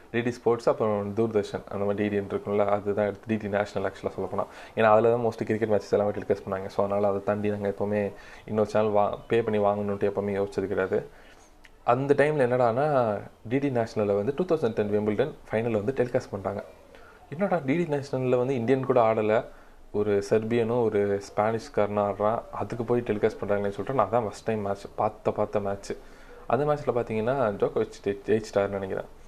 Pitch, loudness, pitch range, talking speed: 105 Hz, -27 LUFS, 100-120 Hz, 170 wpm